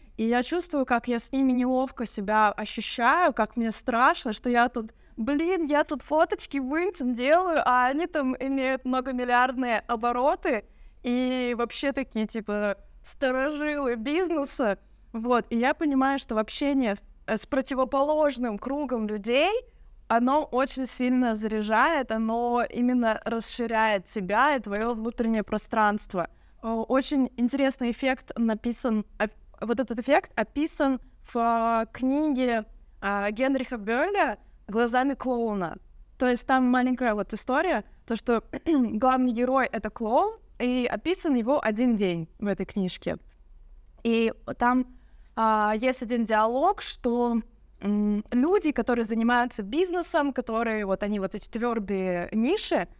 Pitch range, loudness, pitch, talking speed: 220-270 Hz, -26 LUFS, 245 Hz, 130 wpm